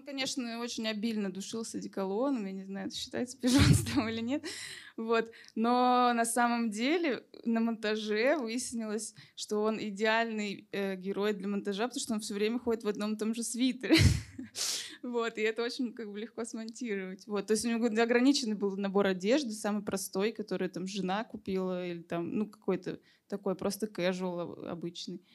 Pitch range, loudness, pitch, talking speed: 200-235 Hz, -32 LUFS, 220 Hz, 170 wpm